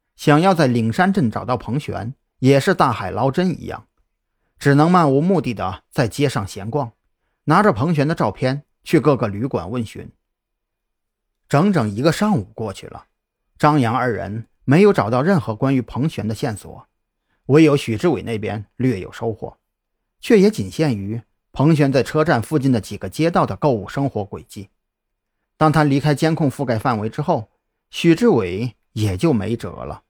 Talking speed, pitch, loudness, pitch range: 250 characters per minute, 130 Hz, -18 LUFS, 110-155 Hz